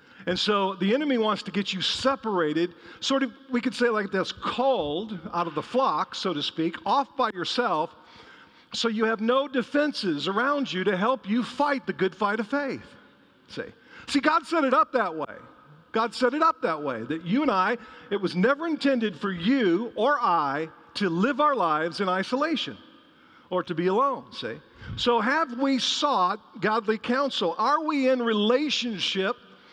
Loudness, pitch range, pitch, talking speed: -26 LUFS, 195-270 Hz, 235 Hz, 180 wpm